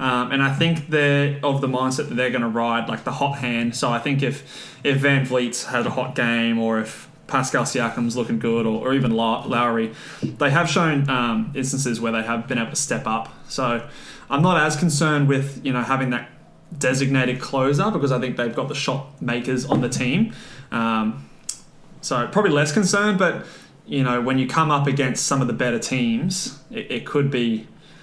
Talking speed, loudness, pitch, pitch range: 205 wpm, -21 LUFS, 130 Hz, 120-145 Hz